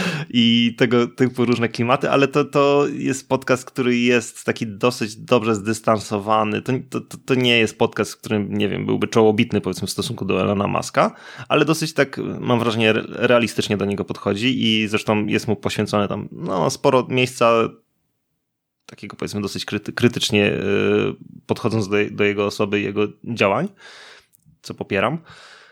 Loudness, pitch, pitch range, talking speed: -20 LUFS, 115 Hz, 105-125 Hz, 150 wpm